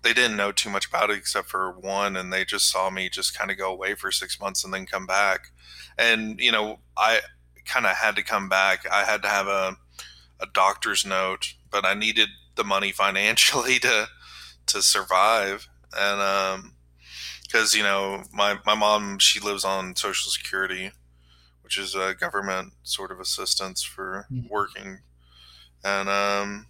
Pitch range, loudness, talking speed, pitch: 60-100 Hz, -23 LUFS, 175 wpm, 95 Hz